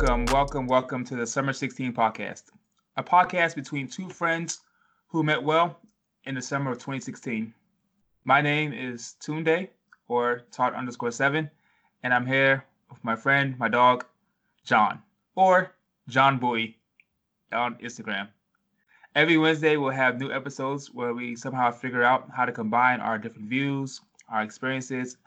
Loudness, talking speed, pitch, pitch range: -25 LUFS, 145 wpm, 135 Hz, 125-155 Hz